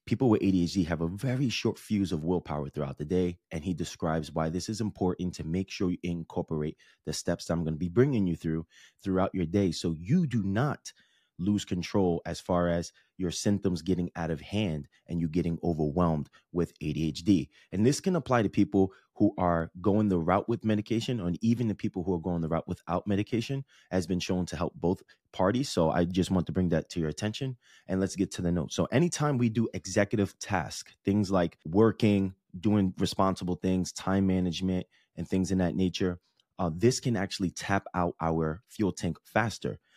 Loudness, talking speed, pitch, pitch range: -30 LUFS, 205 wpm, 90 Hz, 85-105 Hz